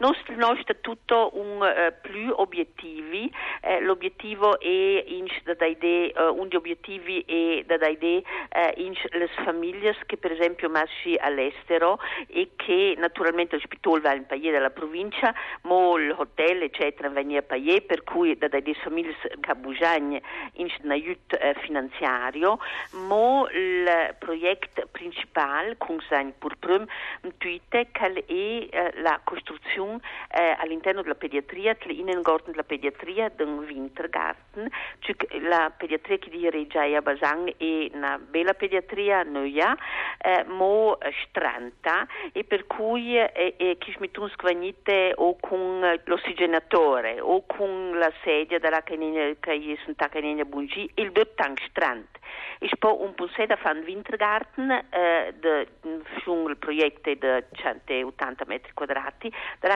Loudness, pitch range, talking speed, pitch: -26 LUFS, 155-220 Hz, 140 wpm, 175 Hz